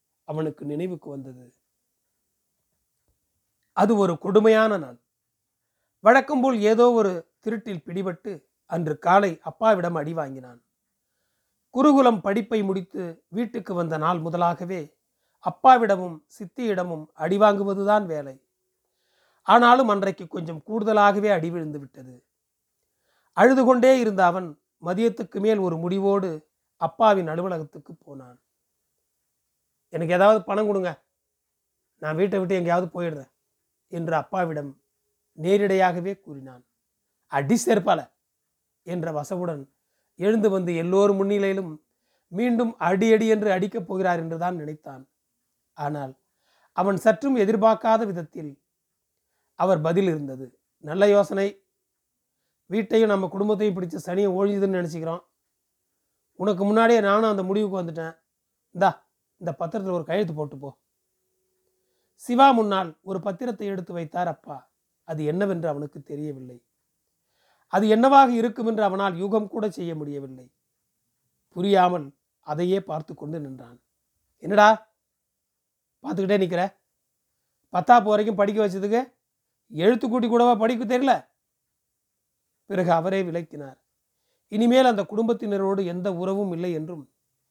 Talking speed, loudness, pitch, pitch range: 105 wpm, -22 LUFS, 185 Hz, 155-215 Hz